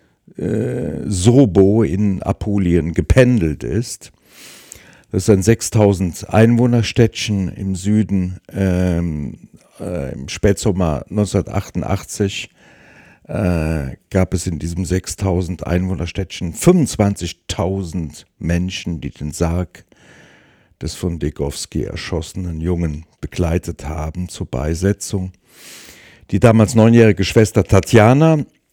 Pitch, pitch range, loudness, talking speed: 95 Hz, 85-105 Hz, -17 LUFS, 85 wpm